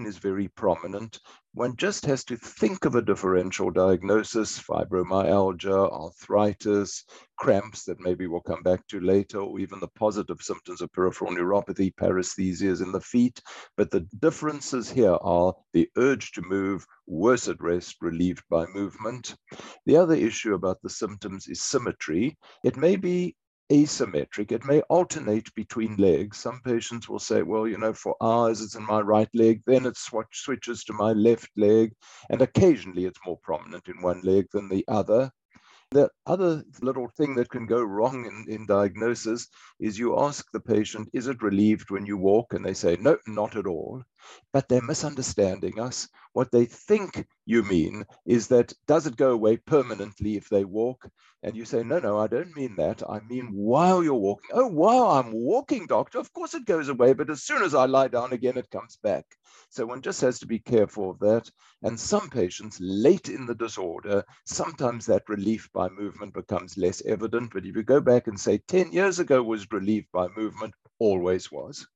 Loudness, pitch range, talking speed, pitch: -25 LUFS, 100-125 Hz, 185 wpm, 110 Hz